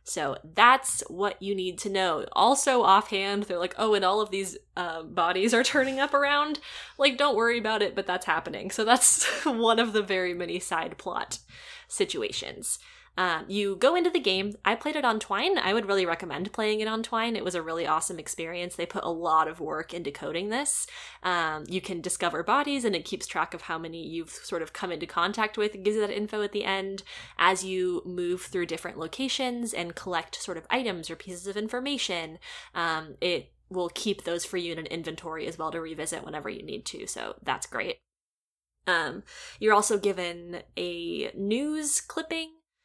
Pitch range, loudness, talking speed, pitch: 170-230 Hz, -28 LUFS, 200 wpm, 195 Hz